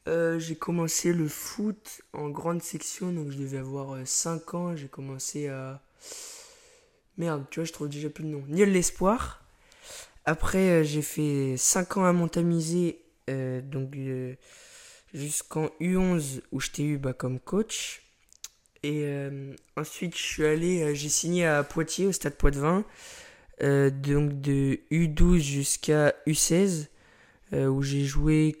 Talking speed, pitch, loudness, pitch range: 155 wpm, 155 Hz, -28 LUFS, 140-175 Hz